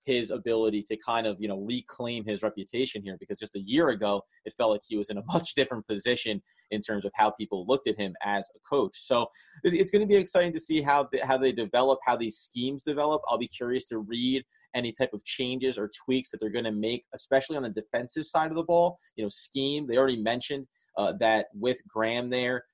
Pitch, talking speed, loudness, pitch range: 120 Hz, 235 wpm, -29 LUFS, 110-135 Hz